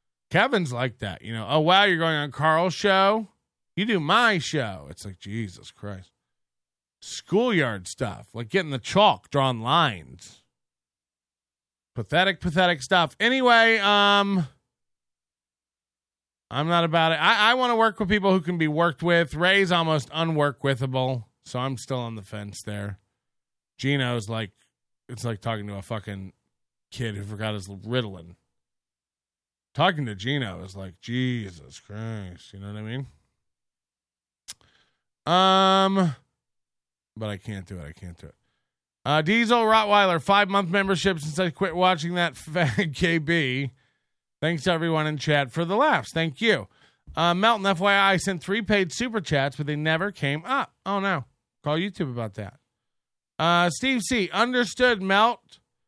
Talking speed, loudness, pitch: 150 wpm, -23 LUFS, 145 Hz